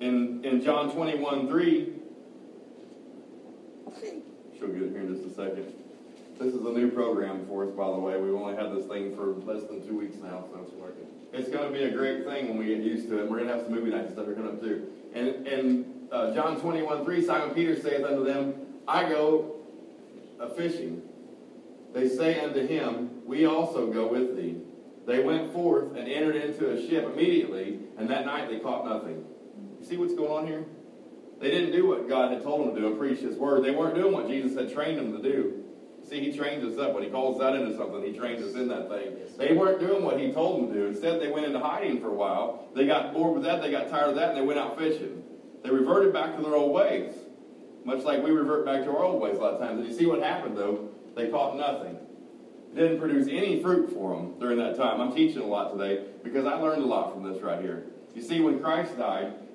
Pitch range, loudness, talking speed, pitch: 115-165 Hz, -28 LUFS, 235 wpm, 140 Hz